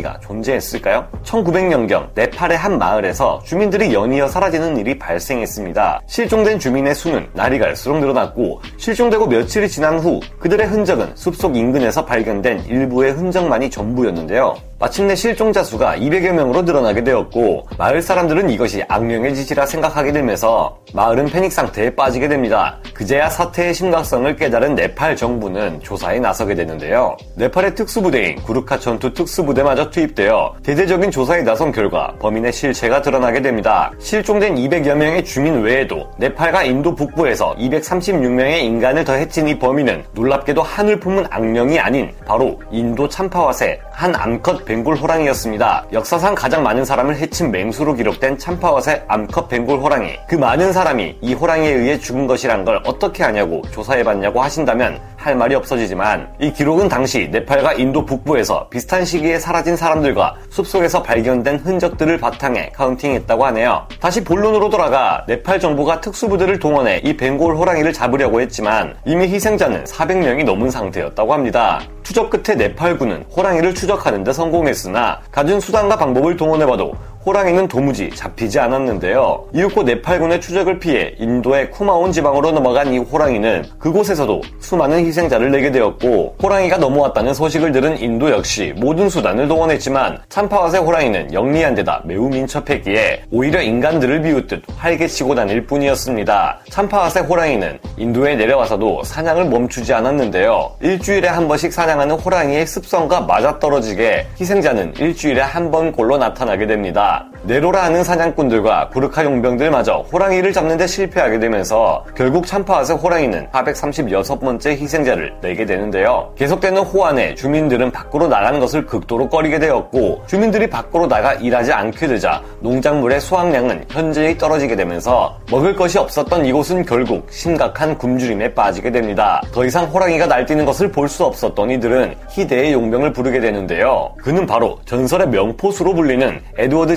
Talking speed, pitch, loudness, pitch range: 390 characters per minute, 155 Hz, -16 LUFS, 130-180 Hz